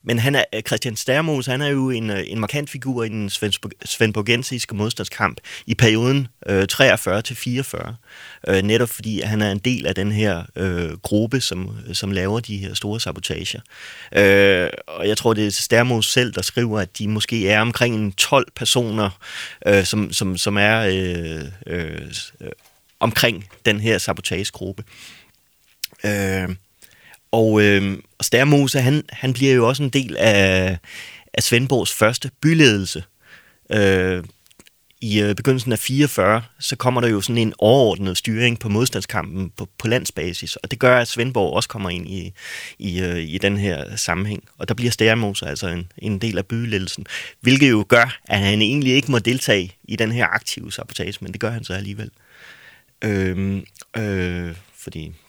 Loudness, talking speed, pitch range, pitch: -19 LUFS, 160 wpm, 95-120 Hz, 105 Hz